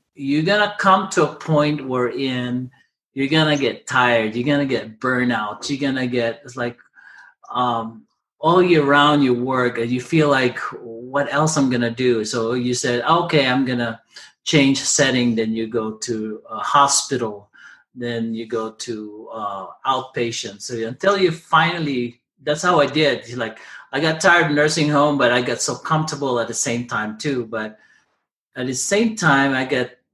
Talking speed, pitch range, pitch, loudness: 175 wpm, 120-150 Hz, 130 Hz, -19 LUFS